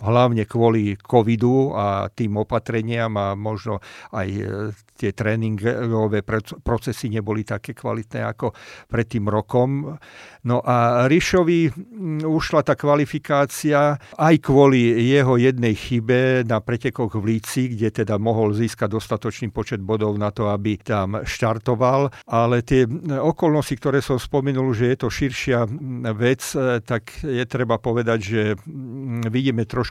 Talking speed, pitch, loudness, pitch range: 130 wpm, 120 Hz, -21 LUFS, 110-135 Hz